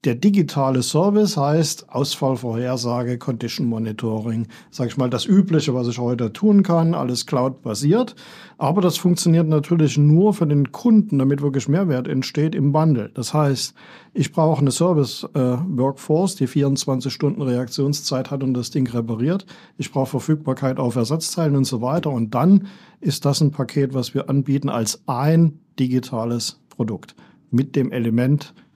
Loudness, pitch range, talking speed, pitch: -20 LUFS, 125-160 Hz, 155 wpm, 140 Hz